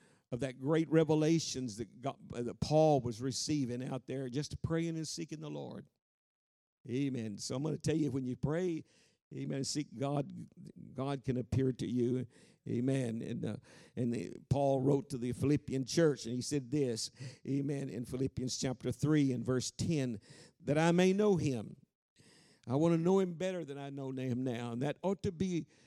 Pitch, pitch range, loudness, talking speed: 135 Hz, 125-155 Hz, -35 LUFS, 185 wpm